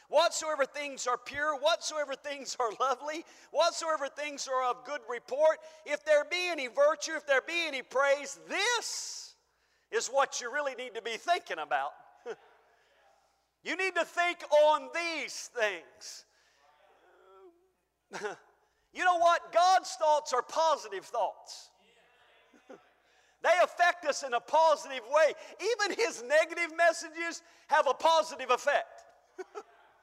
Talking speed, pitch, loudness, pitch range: 130 wpm, 315 Hz, -30 LUFS, 280-345 Hz